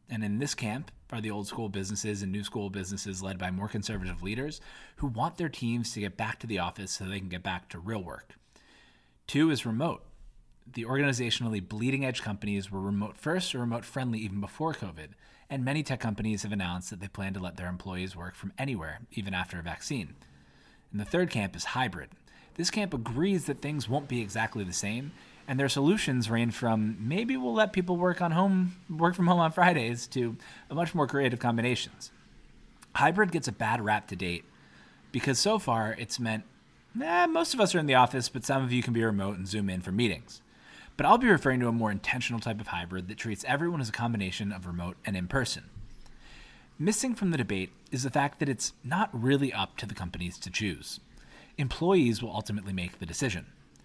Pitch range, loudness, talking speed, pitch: 100-140 Hz, -30 LUFS, 210 wpm, 115 Hz